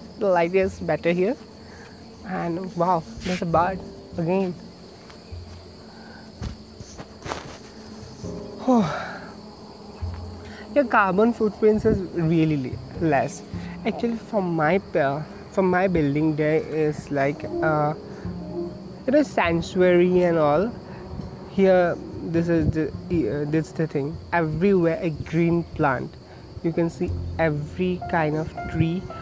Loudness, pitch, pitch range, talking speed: -23 LUFS, 170 Hz, 155-195 Hz, 110 wpm